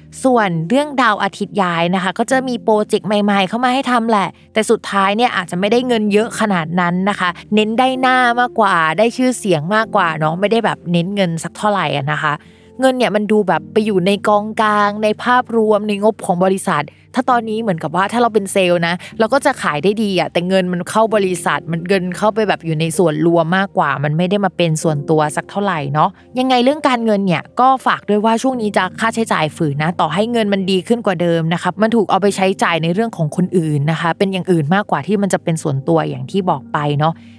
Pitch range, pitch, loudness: 170-220 Hz, 195 Hz, -16 LUFS